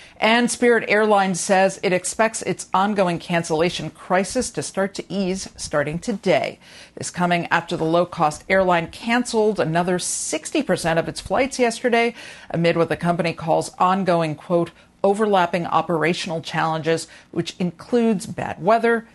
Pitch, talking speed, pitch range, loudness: 185 Hz, 135 wpm, 170-215 Hz, -21 LUFS